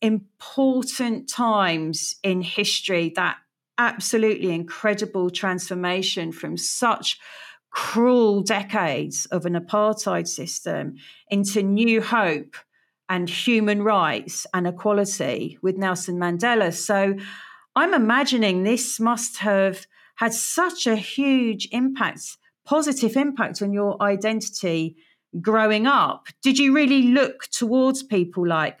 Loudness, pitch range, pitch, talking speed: -22 LUFS, 185-240 Hz, 210 Hz, 110 wpm